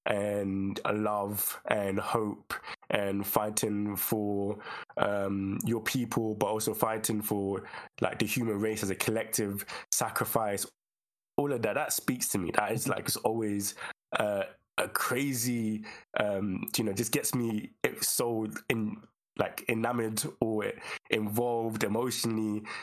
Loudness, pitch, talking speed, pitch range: -31 LUFS, 110 Hz, 135 wpm, 100-115 Hz